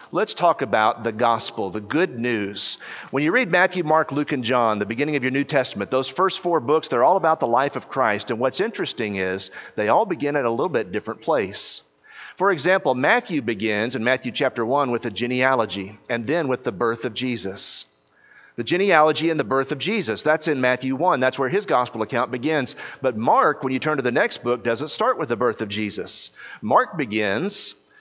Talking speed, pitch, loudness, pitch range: 210 wpm, 130 Hz, -22 LUFS, 115-155 Hz